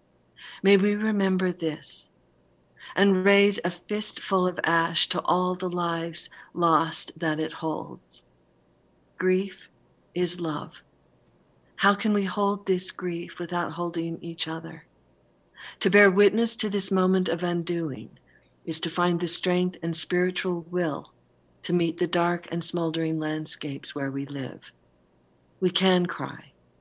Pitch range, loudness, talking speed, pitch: 160-185 Hz, -26 LUFS, 135 wpm, 175 Hz